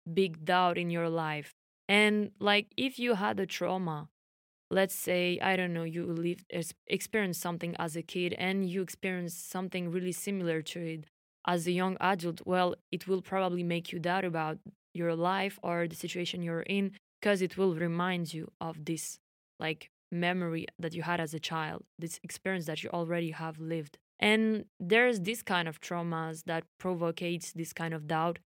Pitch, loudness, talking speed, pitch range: 175 Hz, -32 LUFS, 180 wpm, 165-190 Hz